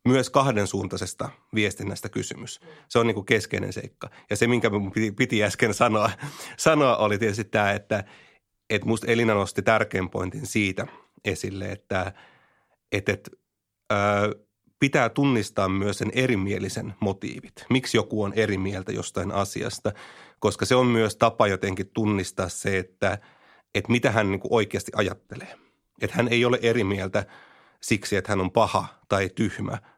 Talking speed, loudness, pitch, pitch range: 150 wpm, -25 LUFS, 105 Hz, 100-115 Hz